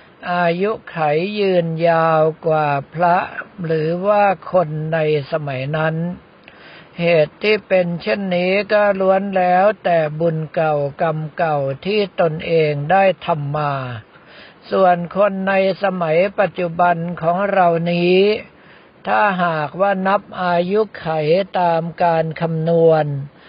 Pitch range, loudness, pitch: 160-190 Hz, -17 LUFS, 170 Hz